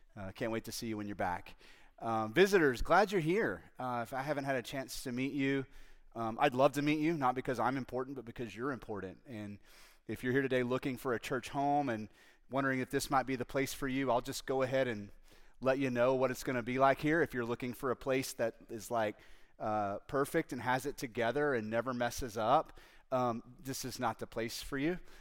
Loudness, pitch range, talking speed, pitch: -35 LUFS, 115-135 Hz, 240 wpm, 125 Hz